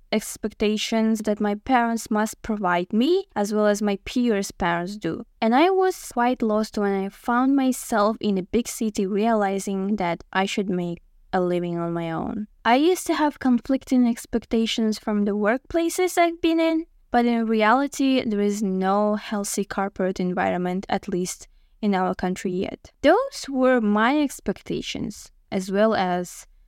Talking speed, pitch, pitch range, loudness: 160 wpm, 215 Hz, 195-245 Hz, -23 LUFS